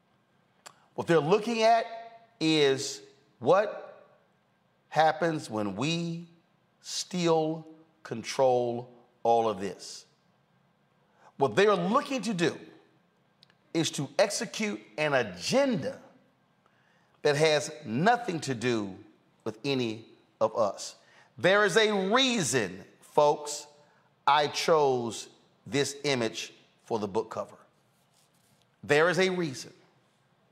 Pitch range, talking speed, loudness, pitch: 135-200 Hz, 100 wpm, -28 LUFS, 160 Hz